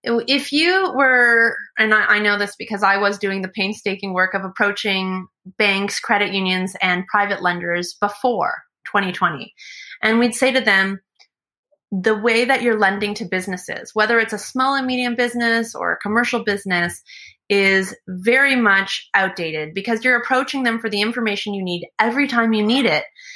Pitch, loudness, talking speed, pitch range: 210 Hz, -18 LUFS, 170 wpm, 195-240 Hz